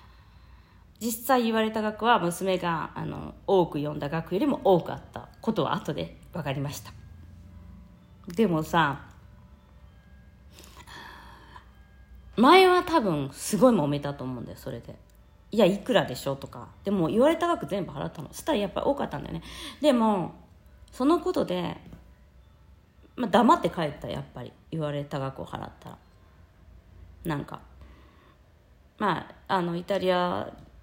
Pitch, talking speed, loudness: 145 Hz, 265 characters per minute, -26 LUFS